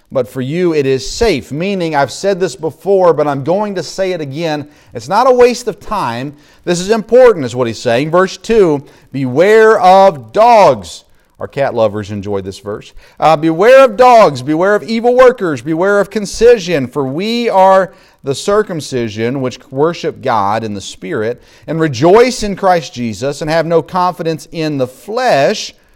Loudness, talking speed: -12 LUFS, 175 wpm